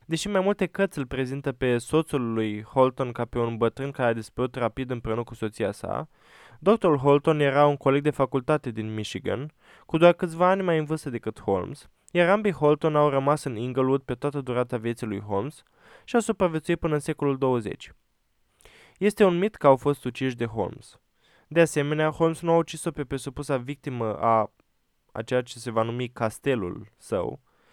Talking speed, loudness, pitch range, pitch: 190 wpm, -25 LUFS, 120-160 Hz, 140 Hz